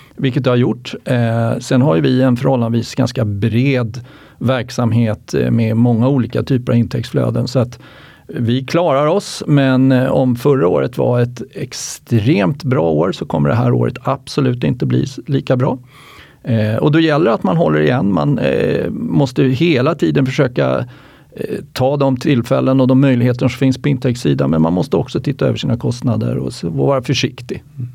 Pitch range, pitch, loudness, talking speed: 120-135 Hz, 130 Hz, -15 LUFS, 175 wpm